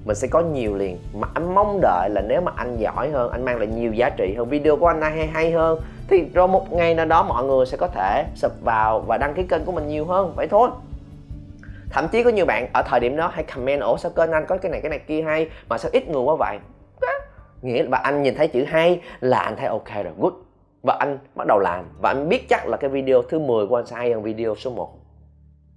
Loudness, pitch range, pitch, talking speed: -21 LUFS, 110-165 Hz, 135 Hz, 270 wpm